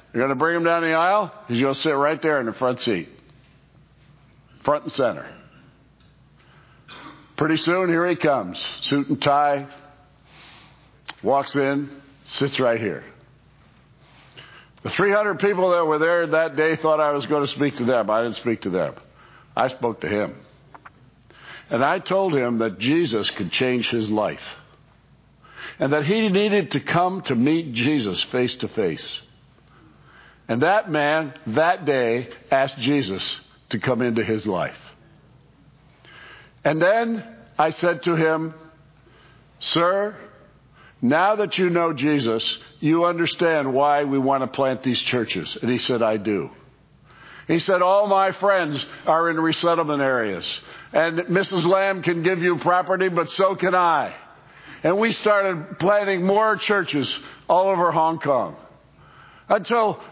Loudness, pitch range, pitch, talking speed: -21 LUFS, 135-180 Hz, 155 Hz, 150 wpm